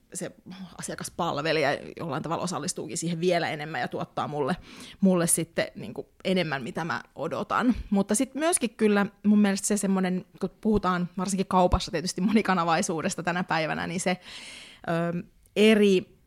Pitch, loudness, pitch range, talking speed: 185 Hz, -26 LUFS, 175-205 Hz, 140 wpm